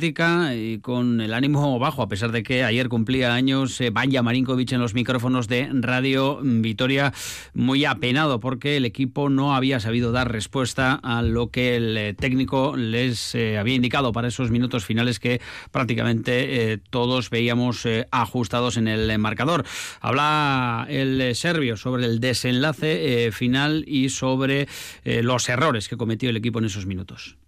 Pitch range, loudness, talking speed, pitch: 115-135 Hz, -22 LUFS, 160 wpm, 125 Hz